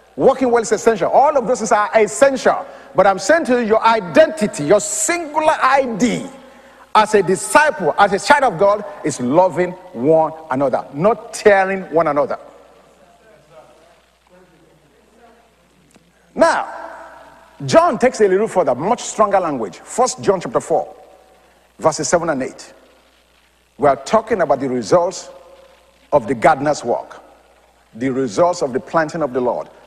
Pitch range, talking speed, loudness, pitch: 175-250 Hz, 145 wpm, -16 LUFS, 210 Hz